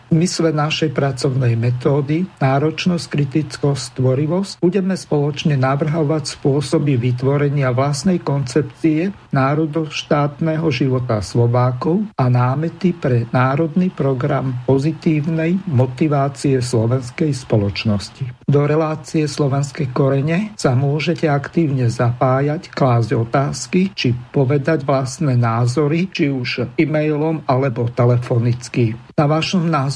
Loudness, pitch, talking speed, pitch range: -18 LUFS, 145 Hz, 100 wpm, 130-160 Hz